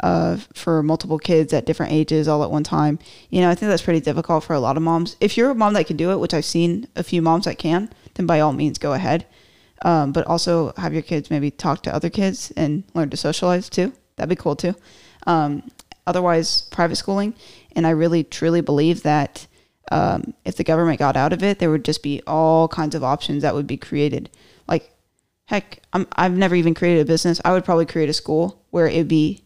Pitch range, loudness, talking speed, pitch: 155-175 Hz, -20 LUFS, 230 wpm, 165 Hz